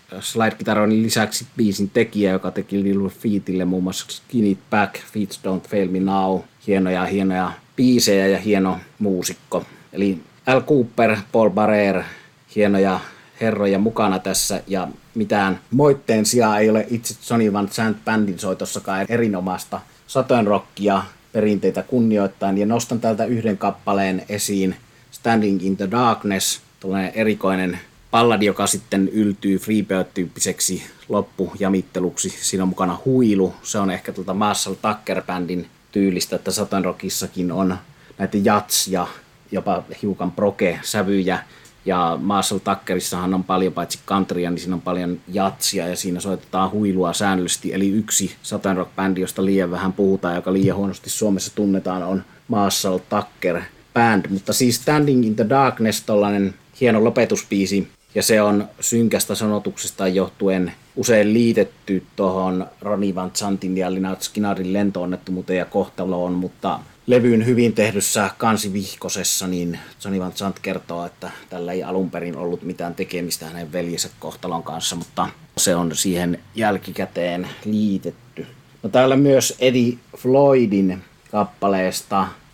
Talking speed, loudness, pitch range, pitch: 135 wpm, -20 LUFS, 95-110 Hz, 100 Hz